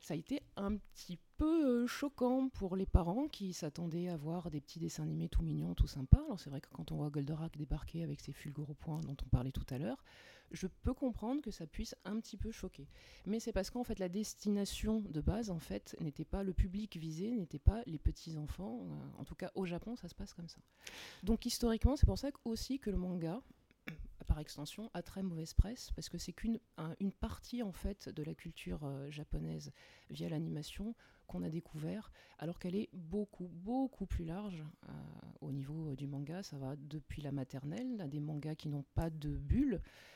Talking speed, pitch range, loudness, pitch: 210 wpm, 150-215 Hz, -41 LUFS, 175 Hz